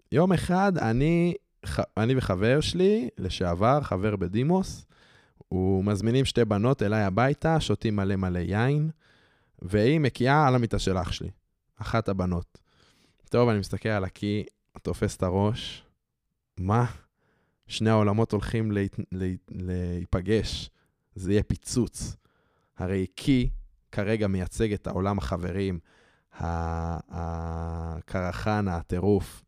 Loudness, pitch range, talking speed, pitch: -27 LUFS, 95-120 Hz, 110 wpm, 105 Hz